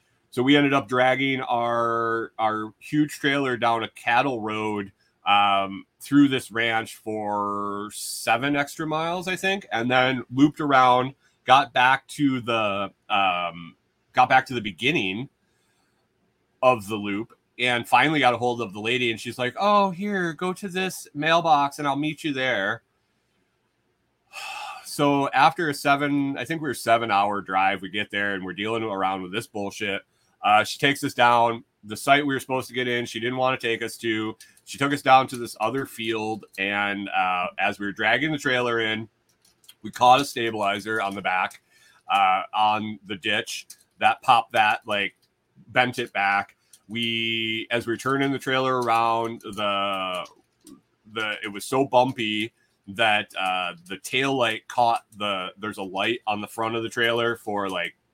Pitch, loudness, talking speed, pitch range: 120 Hz, -23 LUFS, 175 wpm, 110-135 Hz